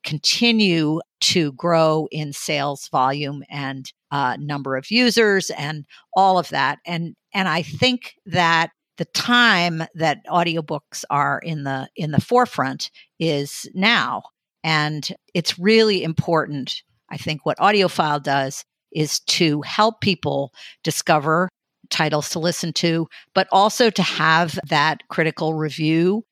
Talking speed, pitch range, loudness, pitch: 130 wpm, 145-180 Hz, -20 LUFS, 160 Hz